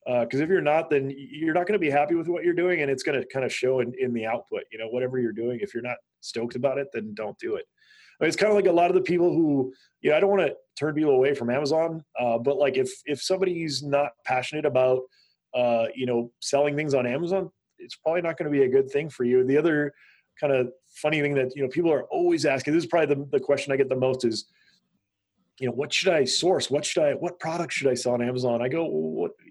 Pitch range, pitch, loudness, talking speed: 130-175 Hz, 145 Hz, -25 LUFS, 275 wpm